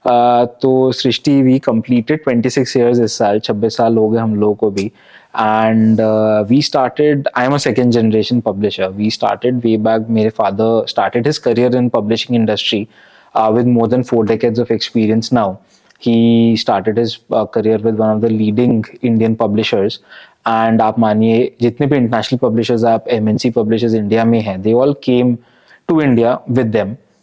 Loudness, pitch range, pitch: -14 LUFS, 110-125 Hz, 115 Hz